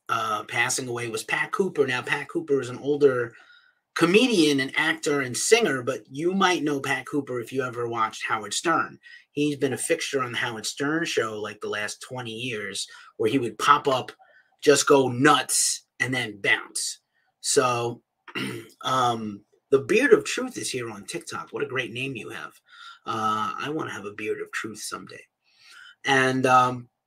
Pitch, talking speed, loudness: 185 Hz, 180 wpm, -24 LUFS